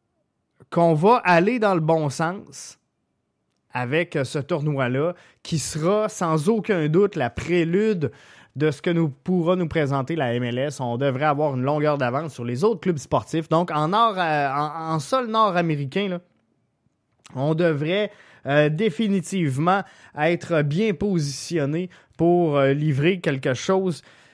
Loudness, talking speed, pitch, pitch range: -22 LUFS, 145 wpm, 160 Hz, 140-180 Hz